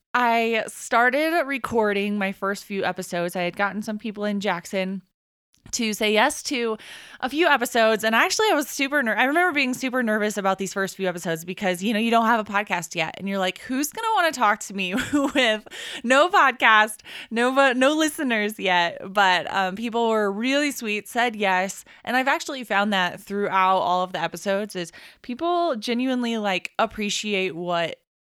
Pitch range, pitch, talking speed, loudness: 195-255 Hz, 215 Hz, 185 wpm, -22 LUFS